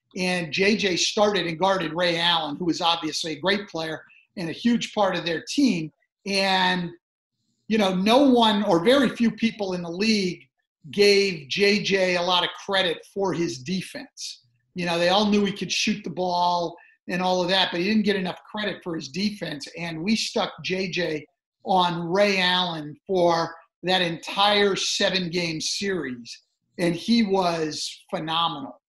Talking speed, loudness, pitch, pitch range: 170 wpm, -23 LUFS, 185 Hz, 170-200 Hz